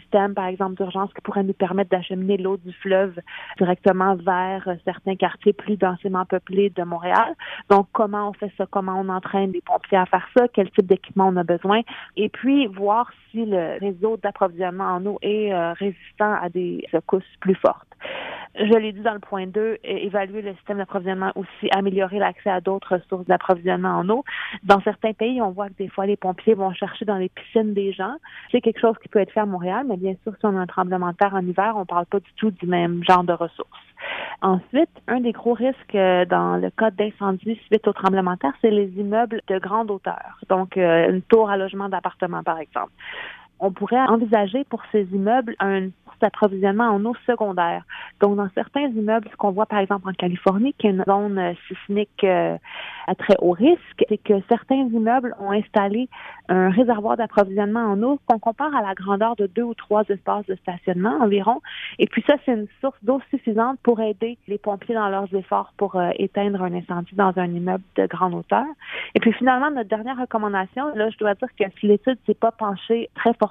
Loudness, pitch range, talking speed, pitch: -22 LUFS, 190-225 Hz, 205 wpm, 200 Hz